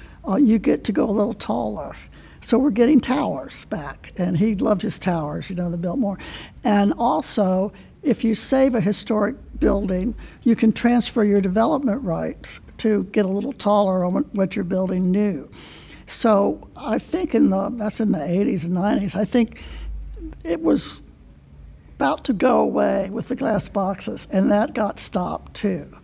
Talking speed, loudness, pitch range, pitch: 170 wpm, -21 LUFS, 190-230 Hz, 205 Hz